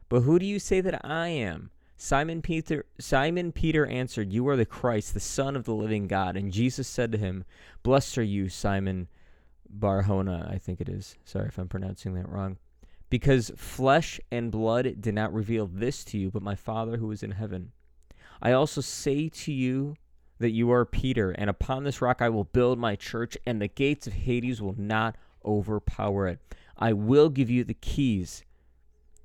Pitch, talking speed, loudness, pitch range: 110 Hz, 190 wpm, -28 LUFS, 95-130 Hz